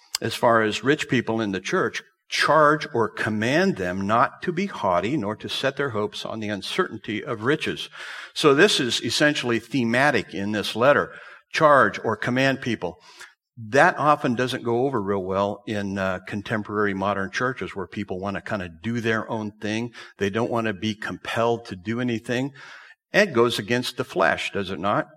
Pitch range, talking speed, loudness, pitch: 100-125 Hz, 185 wpm, -23 LUFS, 110 Hz